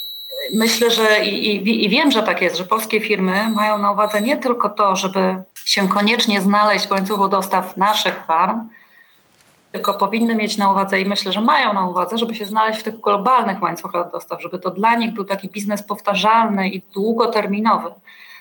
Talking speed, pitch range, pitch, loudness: 185 wpm, 195-220 Hz, 205 Hz, -17 LUFS